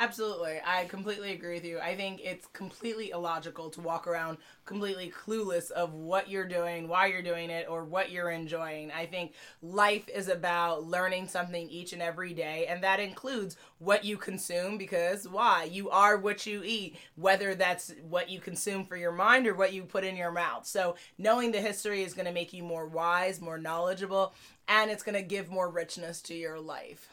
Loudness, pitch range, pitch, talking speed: -31 LUFS, 170-195 Hz, 180 Hz, 200 wpm